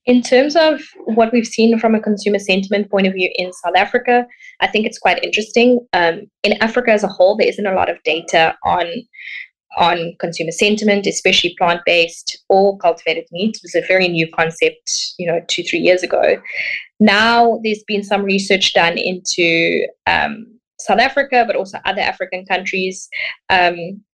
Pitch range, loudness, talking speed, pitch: 180-235 Hz, -15 LUFS, 175 wpm, 205 Hz